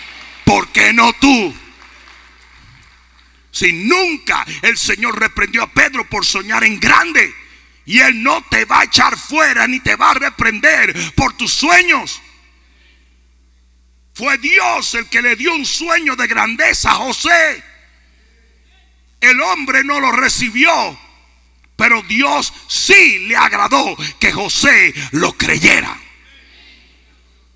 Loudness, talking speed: -11 LUFS, 125 wpm